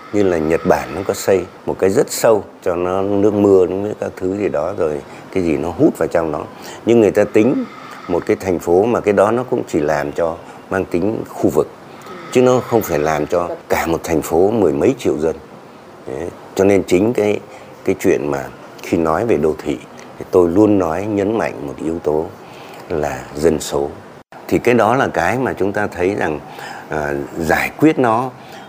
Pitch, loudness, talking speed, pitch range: 100 Hz, -17 LUFS, 210 wpm, 90-110 Hz